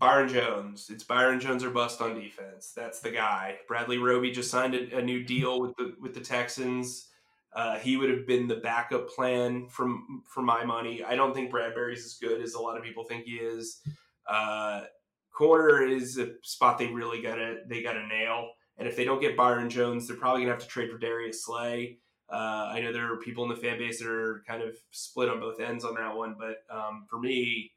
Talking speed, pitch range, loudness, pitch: 225 wpm, 115-125 Hz, -30 LUFS, 120 Hz